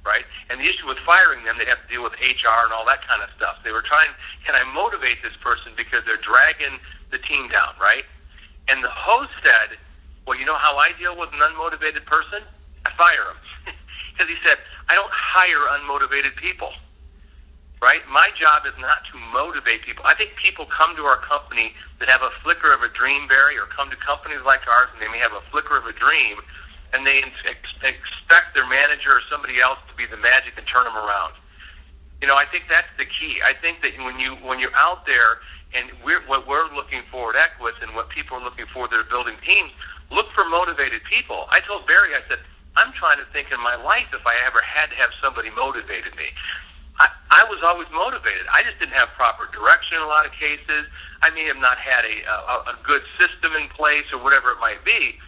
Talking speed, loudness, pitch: 225 wpm, -18 LUFS, 125 Hz